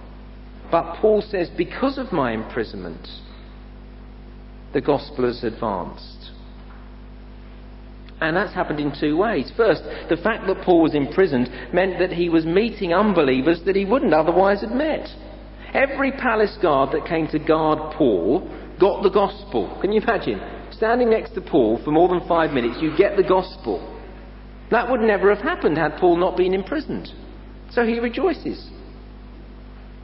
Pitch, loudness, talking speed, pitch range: 175 Hz, -20 LUFS, 150 wpm, 130-205 Hz